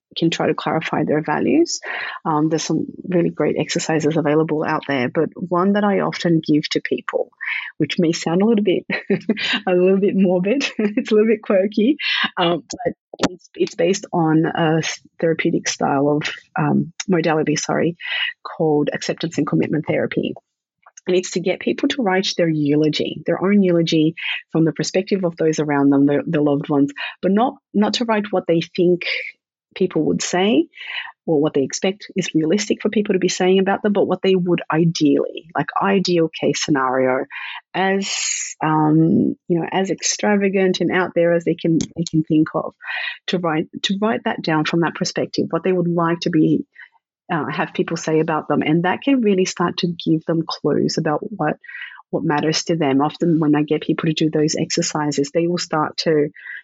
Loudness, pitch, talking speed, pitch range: -19 LUFS, 170 Hz, 190 wpm, 155-195 Hz